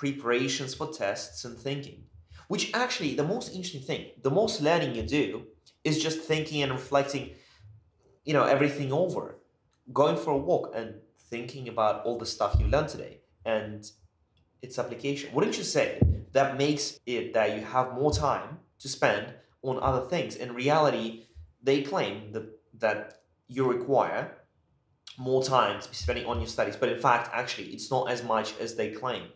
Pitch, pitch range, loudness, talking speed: 130 Hz, 110-145 Hz, -29 LUFS, 170 wpm